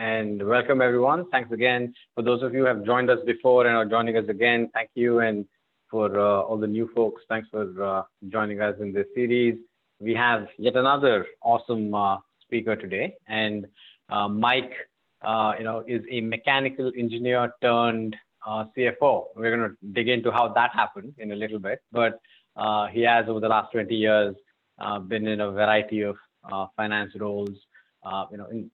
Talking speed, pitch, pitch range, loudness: 190 wpm, 110 Hz, 105-120 Hz, -24 LUFS